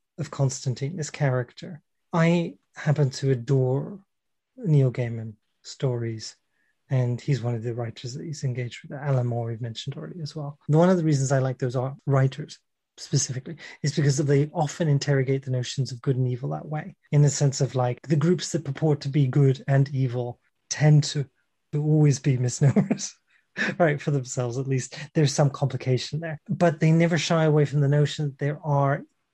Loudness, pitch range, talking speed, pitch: -25 LUFS, 130-155 Hz, 185 wpm, 145 Hz